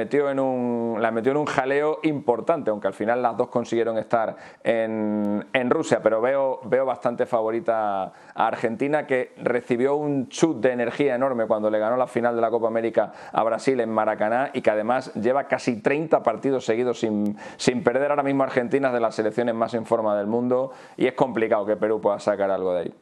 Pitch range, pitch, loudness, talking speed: 110-135 Hz, 120 Hz, -23 LUFS, 205 wpm